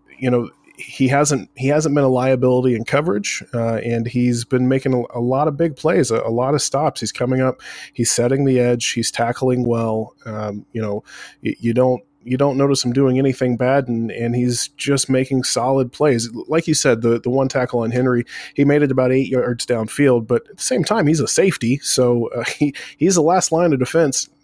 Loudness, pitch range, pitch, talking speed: -18 LUFS, 120-140 Hz, 125 Hz, 220 wpm